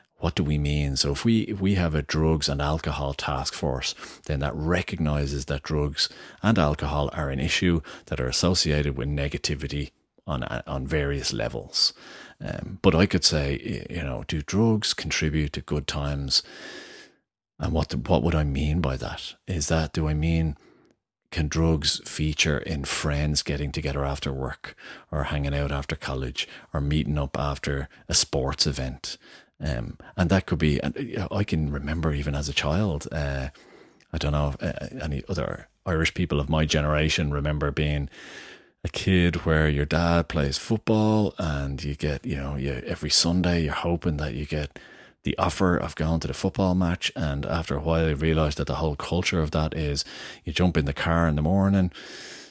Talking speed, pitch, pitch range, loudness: 180 wpm, 75 Hz, 70-85 Hz, -26 LUFS